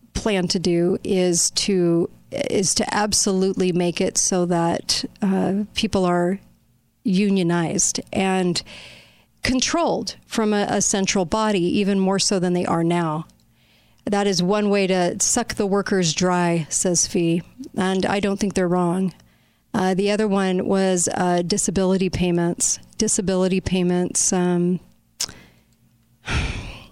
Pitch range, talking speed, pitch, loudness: 175-200 Hz, 135 wpm, 185 Hz, -20 LUFS